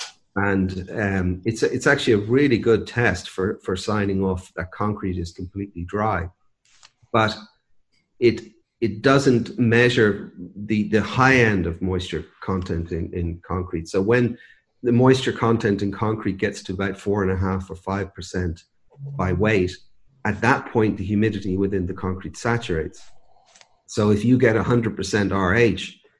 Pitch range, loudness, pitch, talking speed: 95-115 Hz, -22 LUFS, 100 Hz, 160 wpm